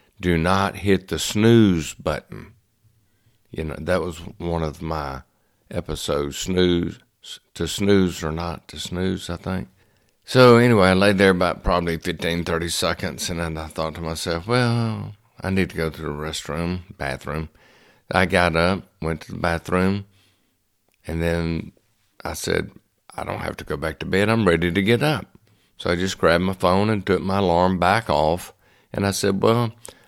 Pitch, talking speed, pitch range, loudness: 90 Hz, 175 wpm, 85-100 Hz, -21 LUFS